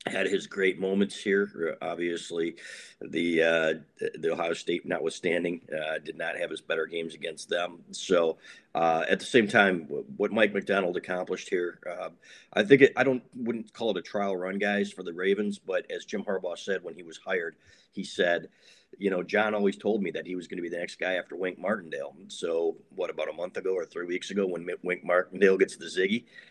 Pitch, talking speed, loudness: 100 Hz, 210 wpm, -29 LUFS